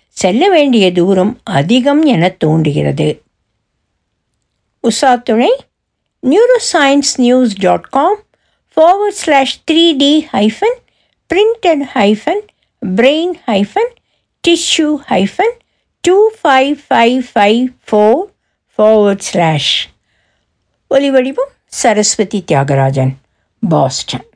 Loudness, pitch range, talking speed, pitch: -11 LUFS, 195-325 Hz, 85 wpm, 255 Hz